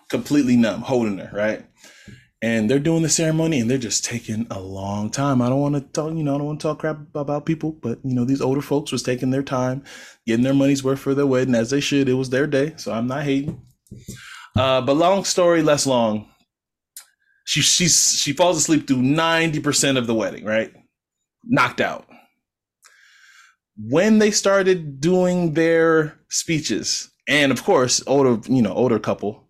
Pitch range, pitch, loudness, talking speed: 125-160 Hz, 140 Hz, -19 LUFS, 190 wpm